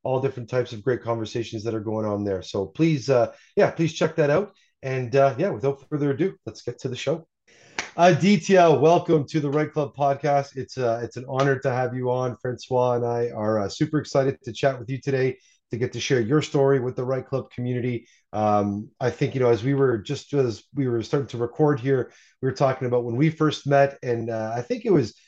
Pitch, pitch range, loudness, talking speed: 130 Hz, 120-145 Hz, -24 LUFS, 235 wpm